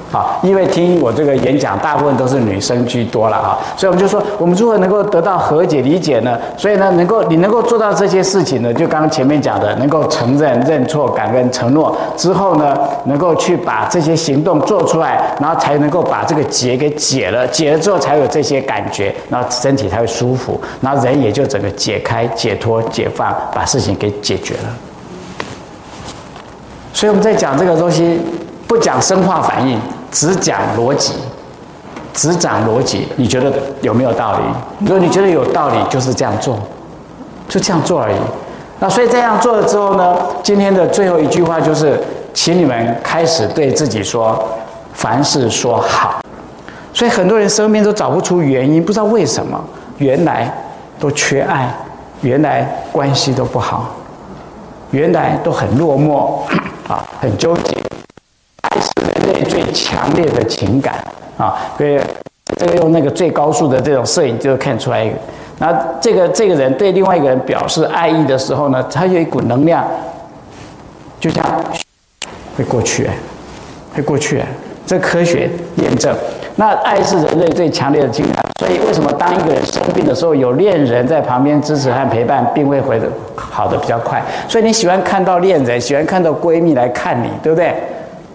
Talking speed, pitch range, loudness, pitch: 270 characters per minute, 130-185 Hz, -13 LUFS, 160 Hz